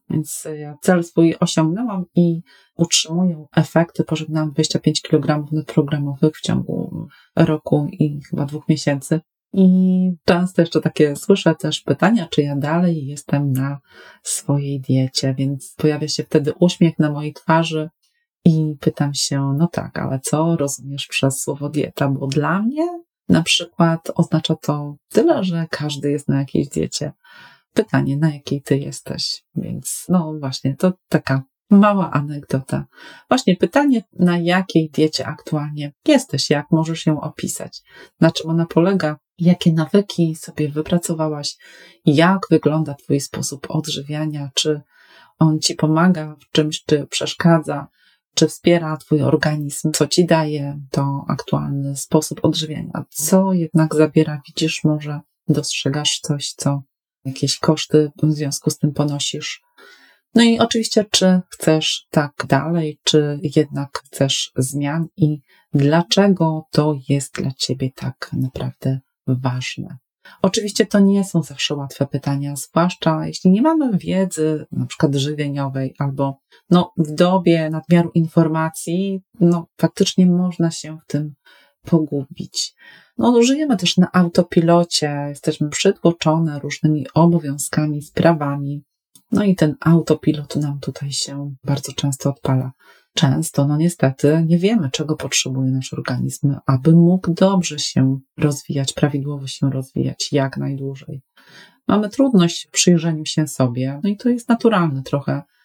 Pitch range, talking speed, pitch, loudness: 145-170 Hz, 135 wpm, 155 Hz, -19 LUFS